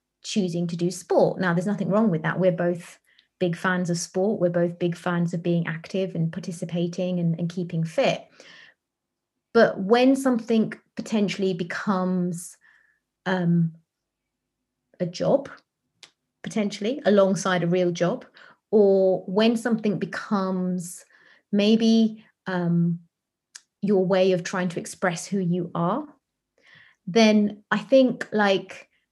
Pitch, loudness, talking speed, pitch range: 185 Hz, -24 LUFS, 125 wpm, 175-210 Hz